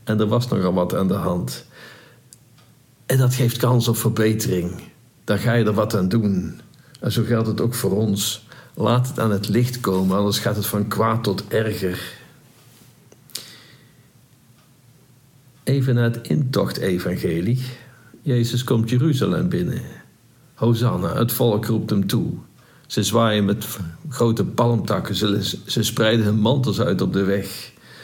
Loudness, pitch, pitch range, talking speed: -21 LUFS, 115 Hz, 105-125 Hz, 150 wpm